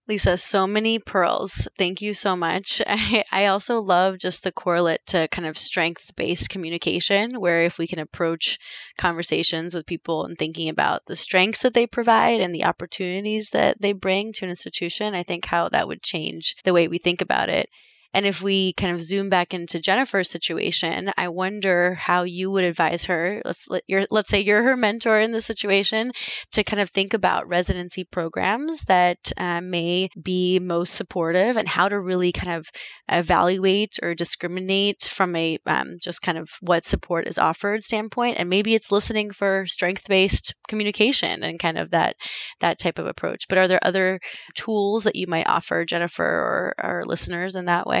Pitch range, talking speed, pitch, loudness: 175-205 Hz, 190 wpm, 185 Hz, -22 LUFS